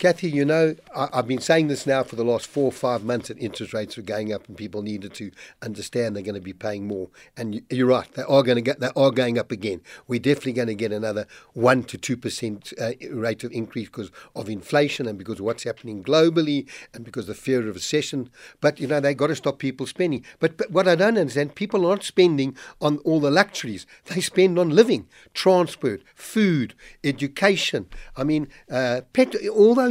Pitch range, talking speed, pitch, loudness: 115-155 Hz, 220 wpm, 130 Hz, -23 LUFS